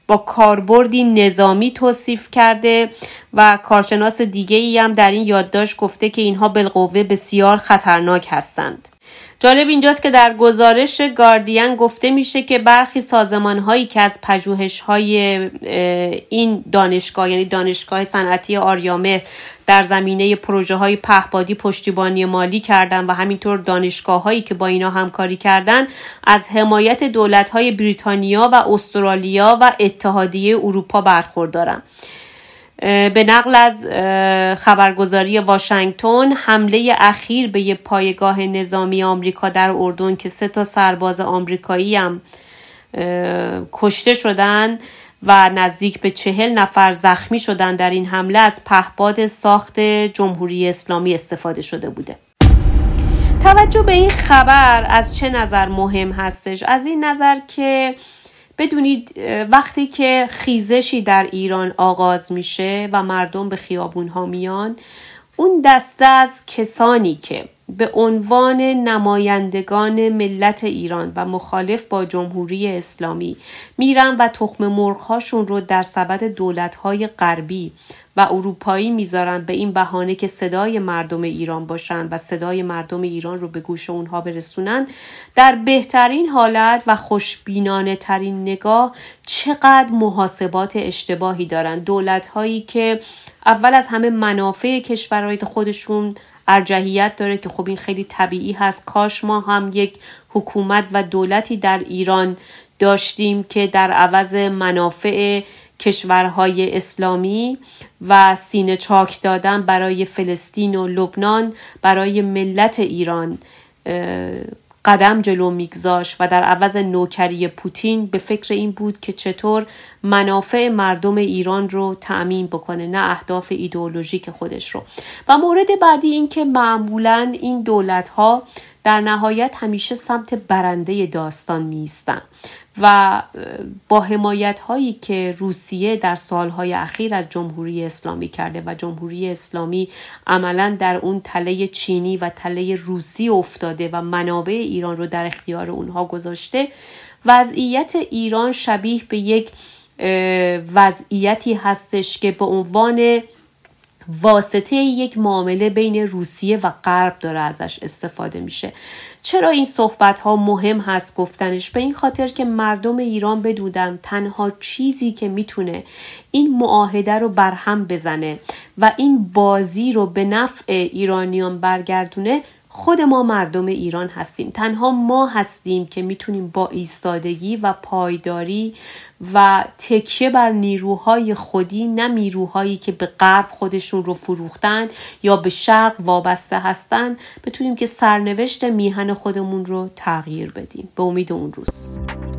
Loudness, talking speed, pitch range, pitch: -15 LUFS, 125 wpm, 185-220 Hz, 200 Hz